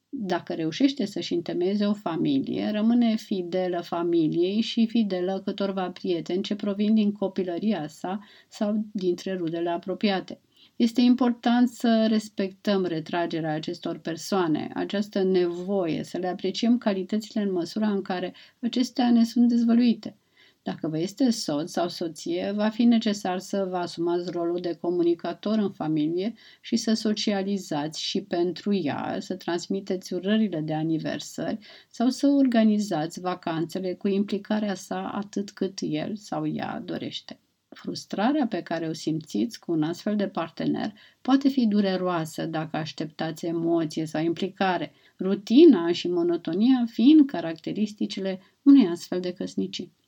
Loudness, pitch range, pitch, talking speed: -26 LUFS, 175-220 Hz, 195 Hz, 135 wpm